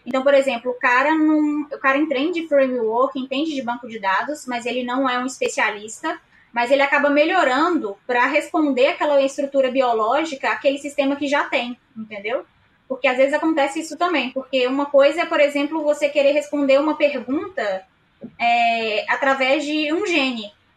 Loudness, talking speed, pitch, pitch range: -19 LUFS, 170 wpm, 275 Hz, 250-295 Hz